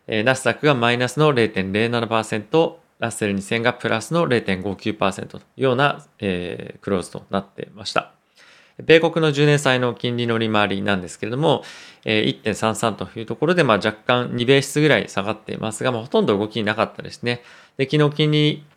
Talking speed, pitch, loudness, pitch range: 330 characters per minute, 120 Hz, -20 LUFS, 110-145 Hz